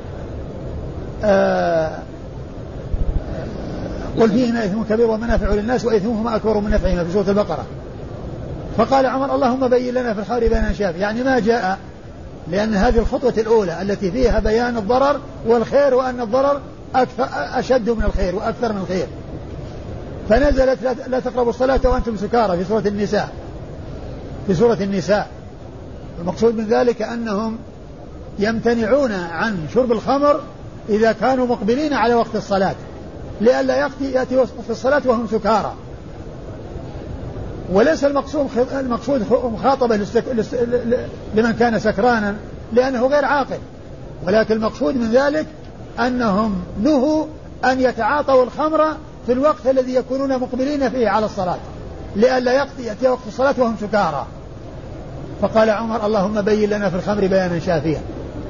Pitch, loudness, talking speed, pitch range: 230 Hz, -18 LUFS, 120 wpm, 205-255 Hz